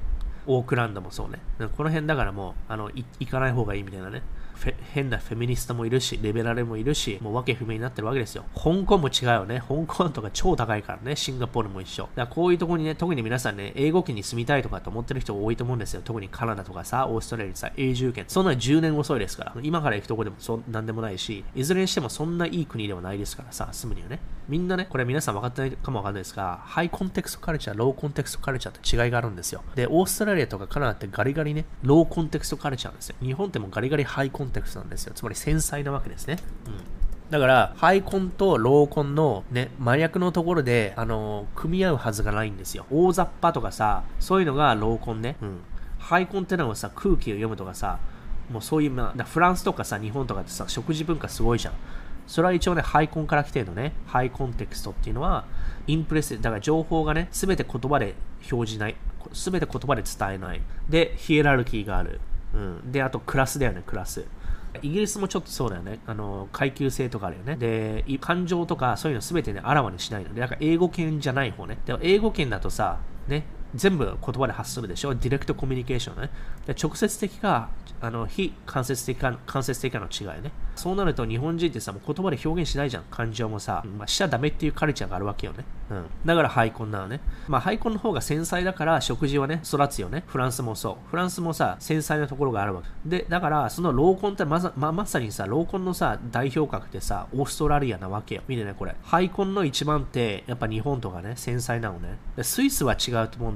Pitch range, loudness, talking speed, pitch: 110-155 Hz, -26 LUFS, 485 characters per minute, 130 Hz